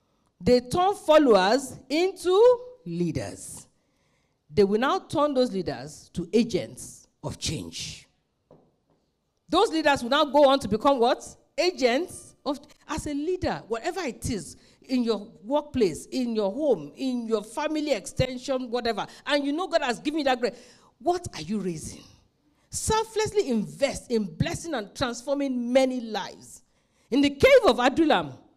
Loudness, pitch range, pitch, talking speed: -25 LUFS, 220-305 Hz, 265 Hz, 145 wpm